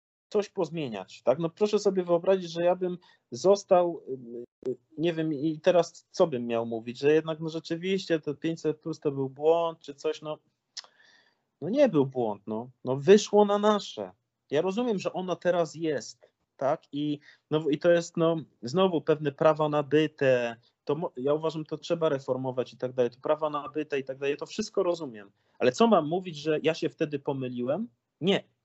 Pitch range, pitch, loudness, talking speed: 140-175 Hz, 155 Hz, -28 LUFS, 180 wpm